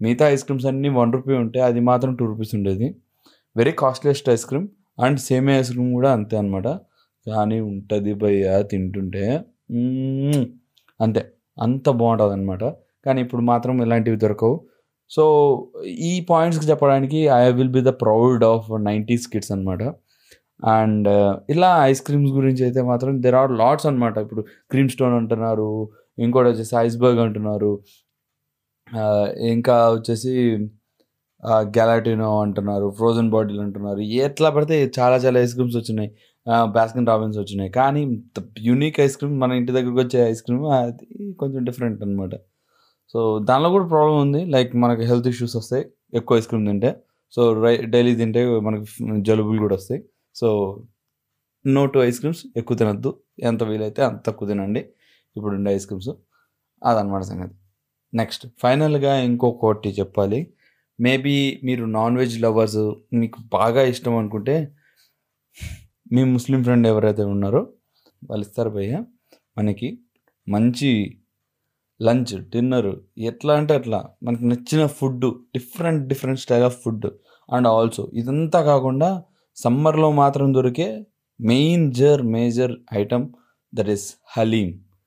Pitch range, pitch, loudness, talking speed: 110-135 Hz, 120 Hz, -20 LUFS, 135 wpm